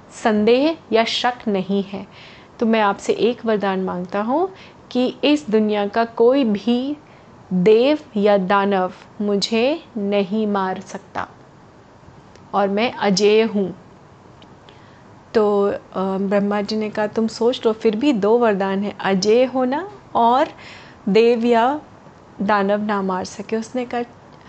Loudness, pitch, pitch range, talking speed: -19 LUFS, 215 Hz, 200-235 Hz, 130 wpm